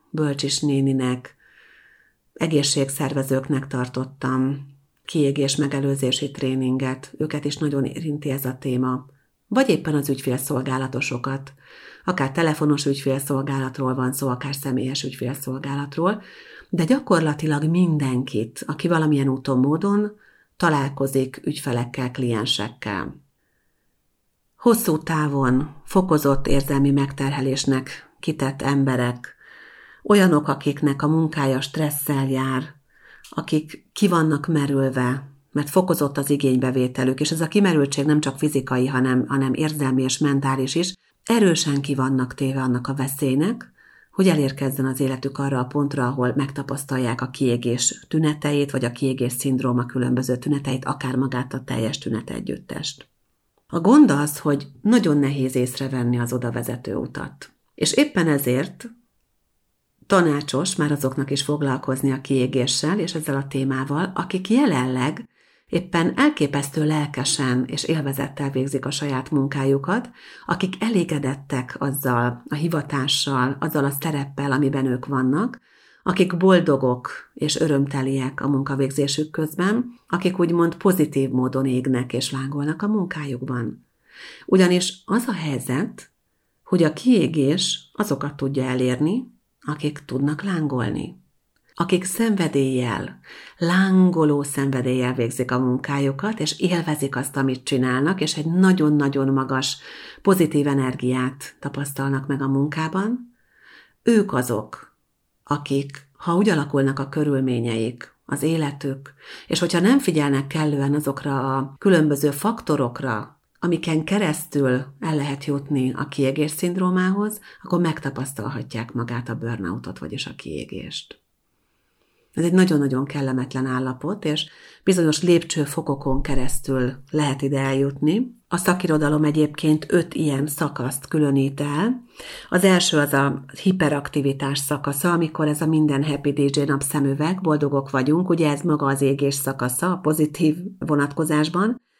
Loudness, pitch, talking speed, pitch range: -22 LUFS, 140 Hz, 120 wpm, 135-160 Hz